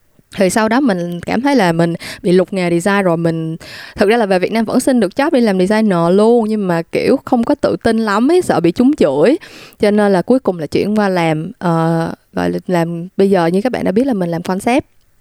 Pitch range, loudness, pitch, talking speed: 170-235 Hz, -14 LUFS, 195 Hz, 255 wpm